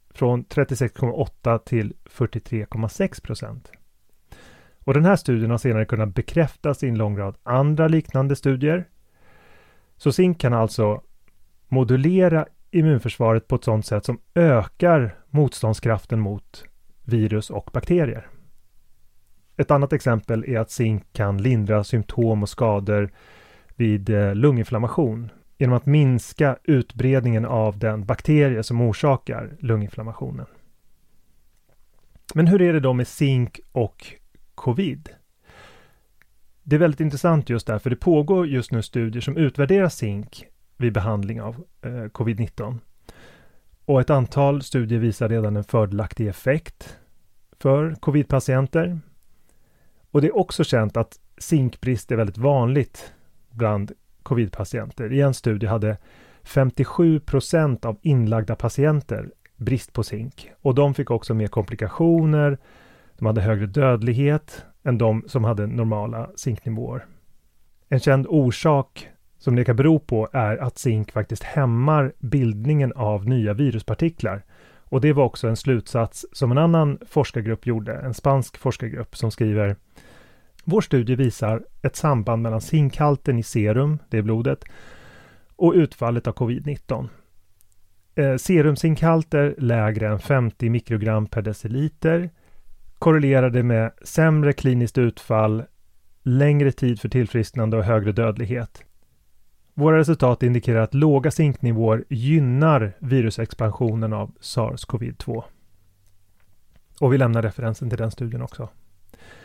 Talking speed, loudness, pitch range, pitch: 125 wpm, -21 LUFS, 110-140 Hz, 120 Hz